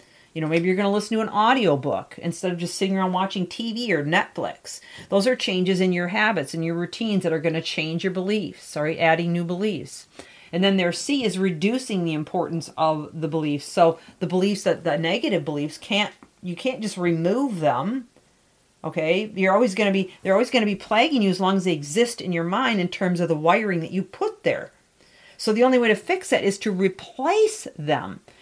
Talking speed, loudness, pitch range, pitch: 220 wpm, -23 LUFS, 170-215 Hz, 190 Hz